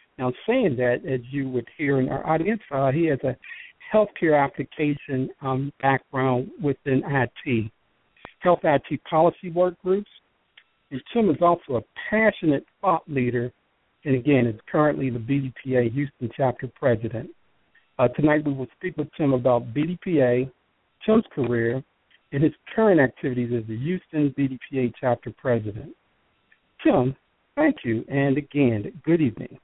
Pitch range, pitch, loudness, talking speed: 125-155 Hz, 135 Hz, -24 LUFS, 140 wpm